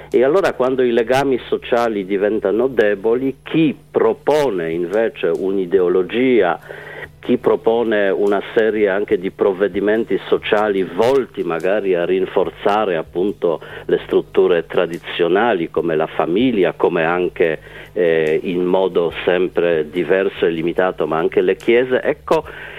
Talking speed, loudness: 120 wpm, -17 LUFS